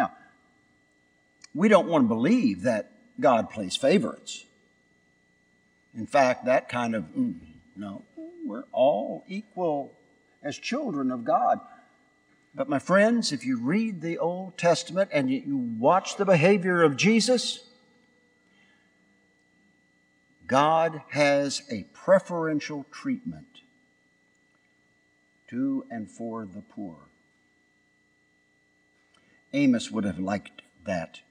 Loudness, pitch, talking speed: -25 LUFS, 165 Hz, 105 wpm